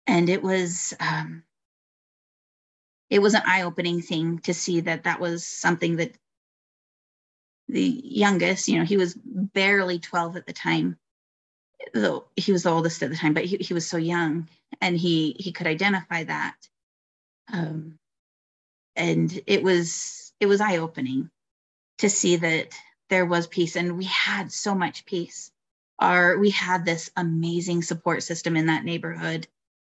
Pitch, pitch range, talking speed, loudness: 175 Hz, 165-190 Hz, 155 wpm, -24 LUFS